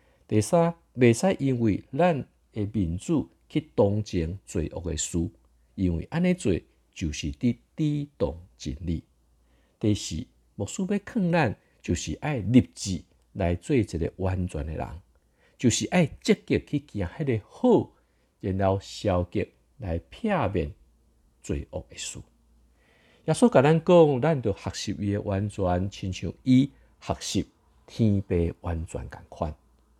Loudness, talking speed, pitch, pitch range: -27 LUFS, 190 characters per minute, 100 Hz, 85-140 Hz